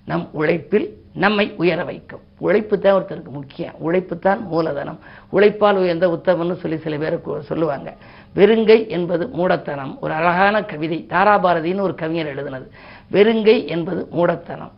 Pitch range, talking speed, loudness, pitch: 165-200 Hz, 130 wpm, -18 LUFS, 175 Hz